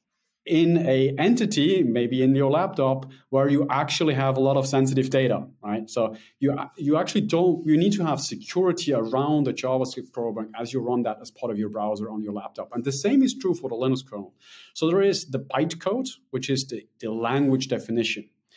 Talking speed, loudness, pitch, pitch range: 205 wpm, -24 LUFS, 135 Hz, 120-165 Hz